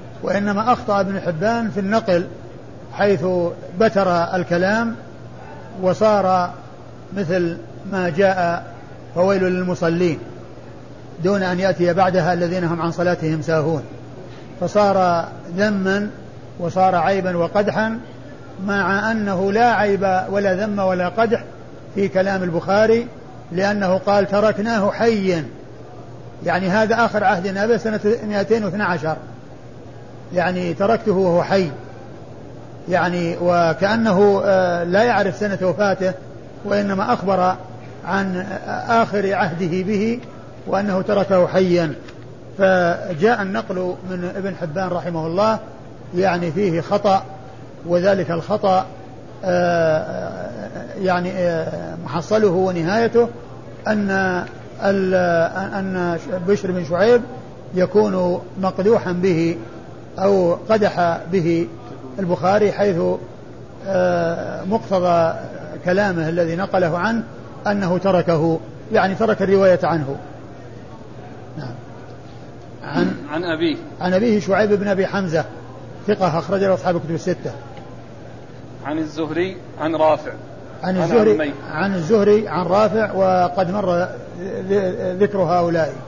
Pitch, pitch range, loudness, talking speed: 185 Hz, 165-200 Hz, -19 LUFS, 95 wpm